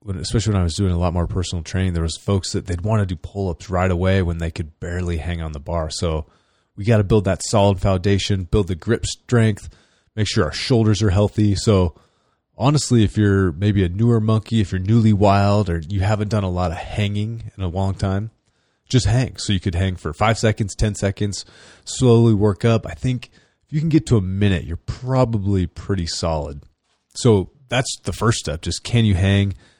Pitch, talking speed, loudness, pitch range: 100 Hz, 220 wpm, -20 LUFS, 90-110 Hz